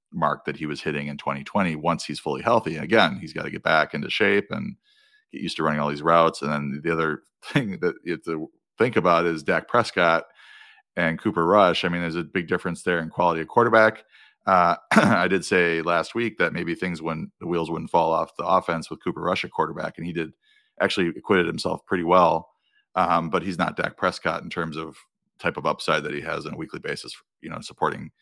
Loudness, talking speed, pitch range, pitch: -23 LUFS, 230 wpm, 80-100 Hz, 85 Hz